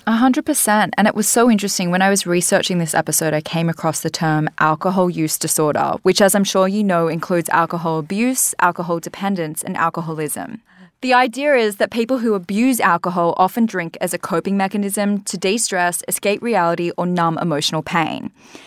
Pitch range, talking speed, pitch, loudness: 165-210 Hz, 180 wpm, 185 Hz, -17 LUFS